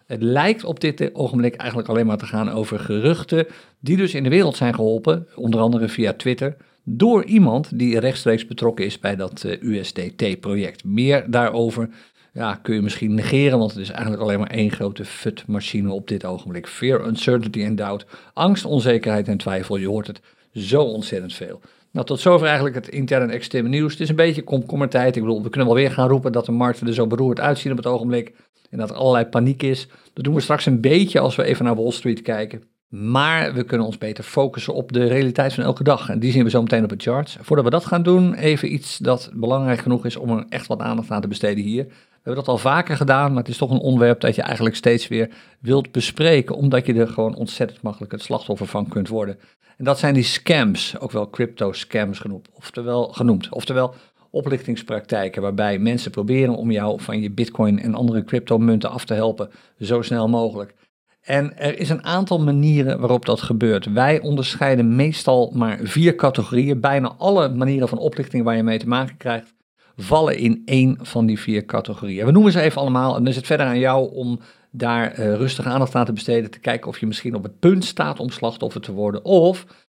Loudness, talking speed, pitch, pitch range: -20 LUFS, 215 wpm, 120 Hz, 110-140 Hz